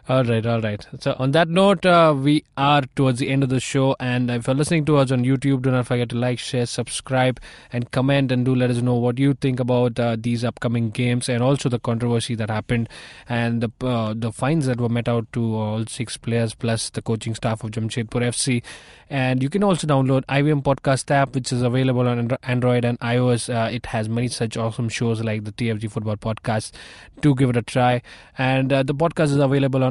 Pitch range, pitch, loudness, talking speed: 115-135 Hz, 125 Hz, -21 LUFS, 225 wpm